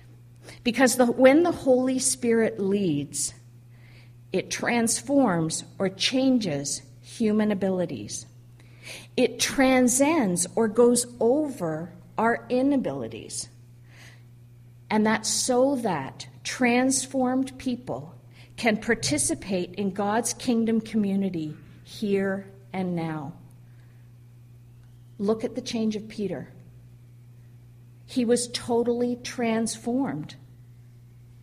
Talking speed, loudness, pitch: 85 wpm, -25 LUFS, 190 Hz